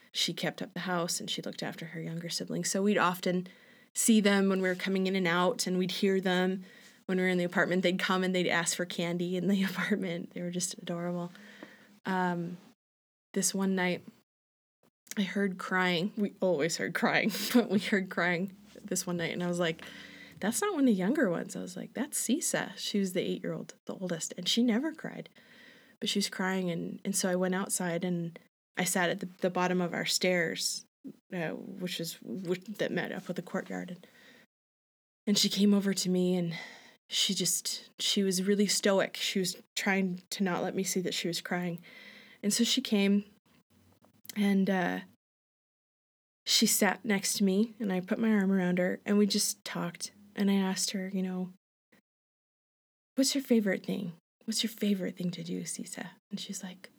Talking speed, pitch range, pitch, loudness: 200 wpm, 180-215 Hz, 195 Hz, -31 LUFS